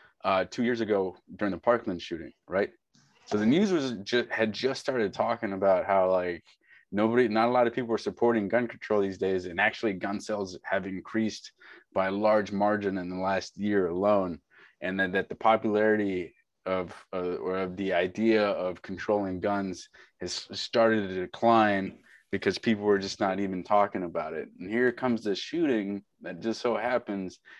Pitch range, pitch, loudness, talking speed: 95-115 Hz, 105 Hz, -28 LUFS, 185 wpm